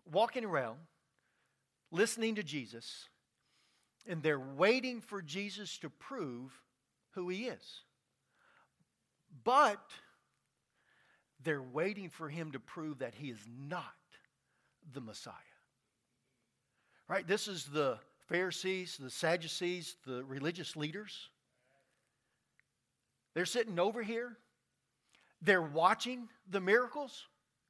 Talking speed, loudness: 100 wpm, -36 LUFS